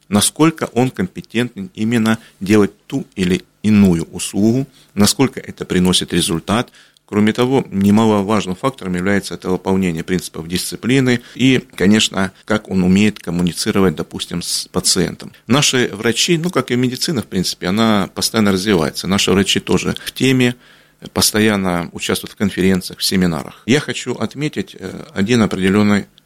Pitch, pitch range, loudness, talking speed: 105 Hz, 95-125 Hz, -16 LUFS, 135 wpm